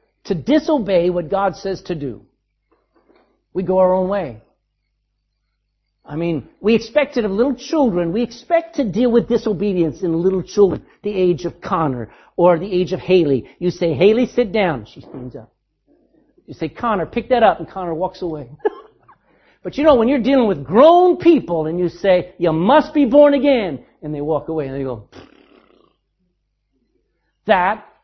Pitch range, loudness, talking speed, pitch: 165-245 Hz, -17 LUFS, 175 wpm, 185 Hz